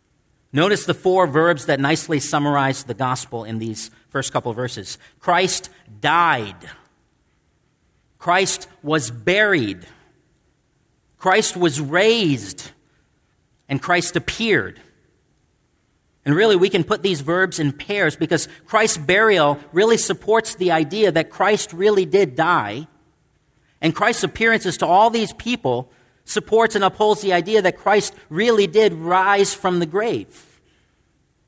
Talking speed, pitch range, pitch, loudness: 130 wpm, 145-200 Hz, 175 Hz, -18 LUFS